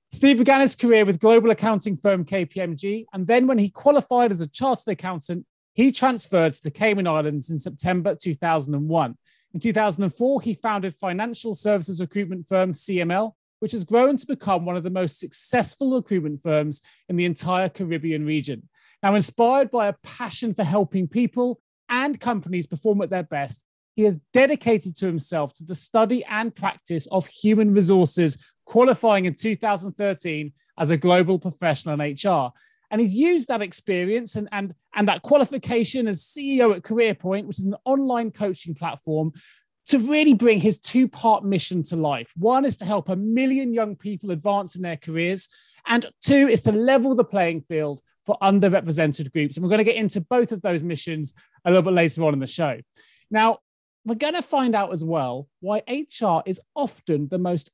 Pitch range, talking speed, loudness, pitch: 170-230 Hz, 180 wpm, -22 LUFS, 195 Hz